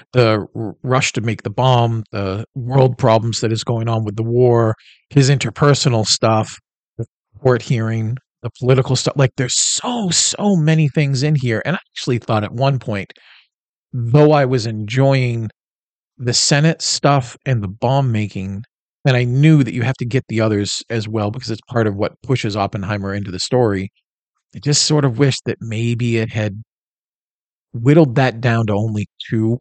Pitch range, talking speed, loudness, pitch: 110-135 Hz, 180 wpm, -17 LUFS, 120 Hz